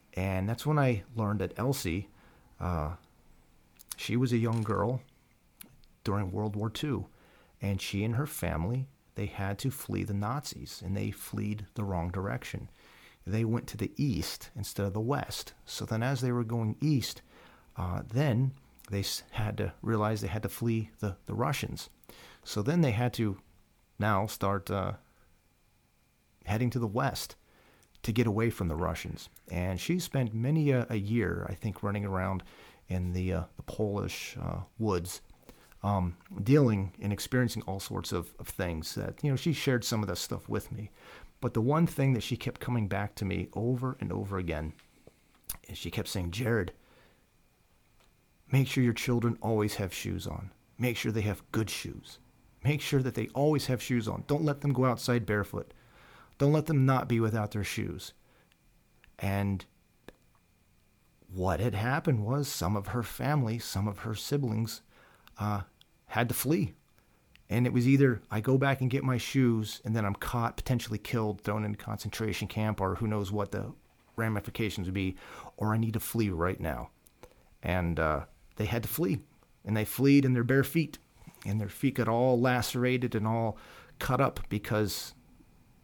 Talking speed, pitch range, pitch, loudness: 175 wpm, 100-125 Hz, 110 Hz, -32 LUFS